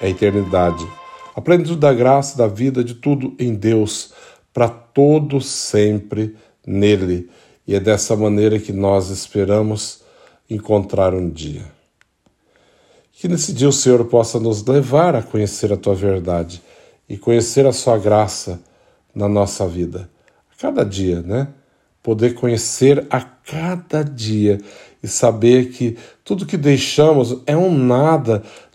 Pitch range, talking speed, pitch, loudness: 100-135 Hz, 135 wpm, 115 Hz, -17 LUFS